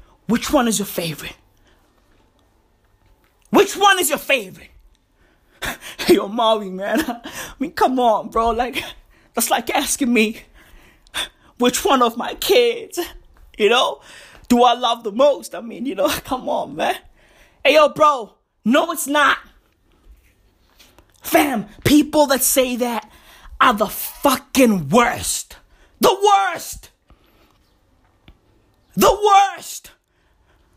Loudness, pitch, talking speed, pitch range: -18 LUFS, 255 Hz, 120 wpm, 220-315 Hz